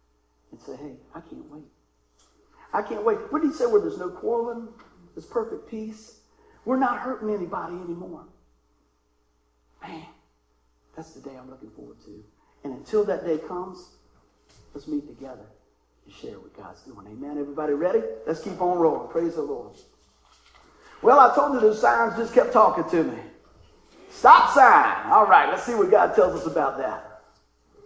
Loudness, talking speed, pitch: -21 LUFS, 170 wpm, 180 Hz